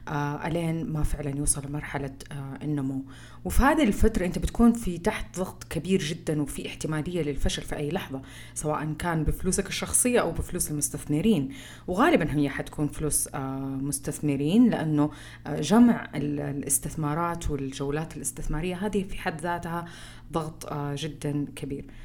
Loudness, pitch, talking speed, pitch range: -27 LUFS, 150 Hz, 140 wpm, 145-175 Hz